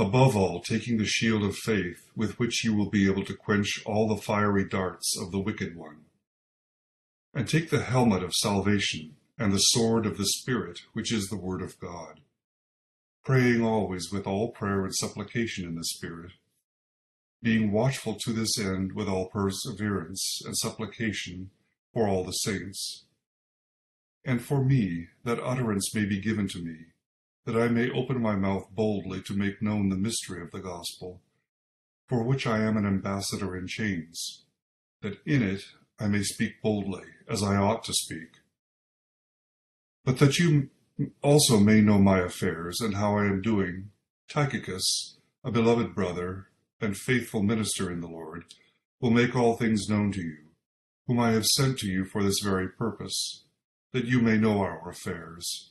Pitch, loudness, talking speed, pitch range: 105 Hz, -27 LUFS, 170 wpm, 95-115 Hz